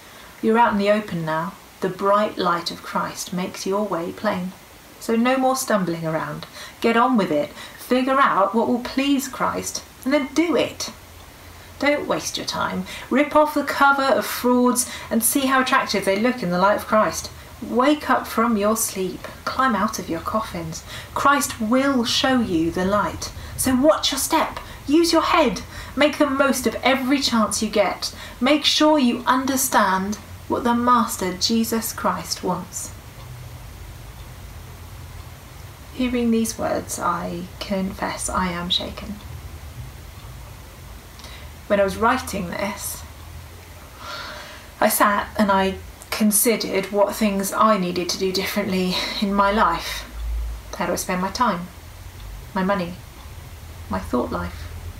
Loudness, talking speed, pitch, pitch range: -21 LUFS, 145 wpm, 200 Hz, 165-245 Hz